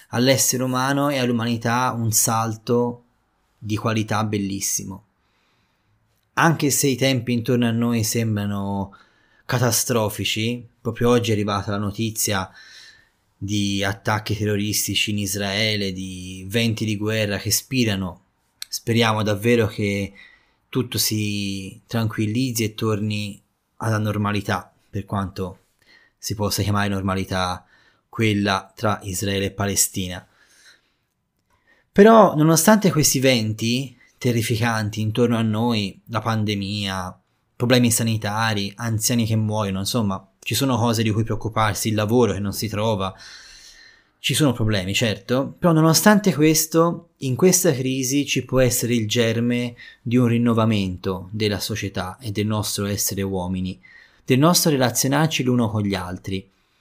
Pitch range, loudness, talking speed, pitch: 100-120 Hz, -21 LUFS, 125 wpm, 110 Hz